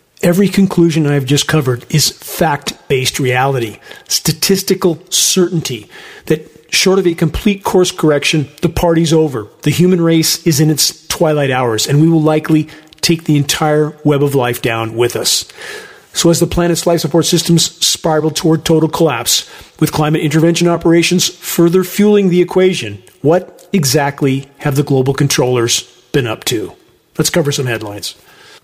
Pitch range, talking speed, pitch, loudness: 145-175 Hz, 155 wpm, 160 Hz, -13 LUFS